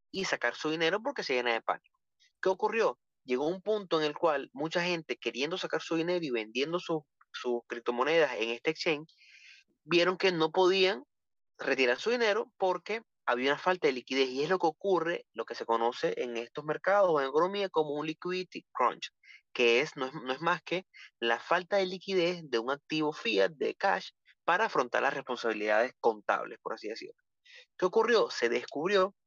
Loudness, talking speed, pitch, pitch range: -31 LUFS, 190 wpm, 165 Hz, 135-190 Hz